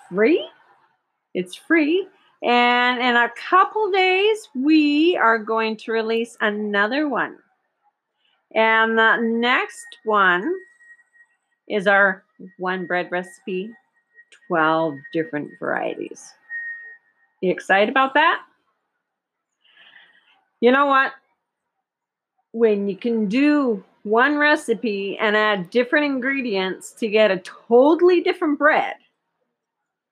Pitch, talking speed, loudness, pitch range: 240 Hz, 100 wpm, -19 LUFS, 210-340 Hz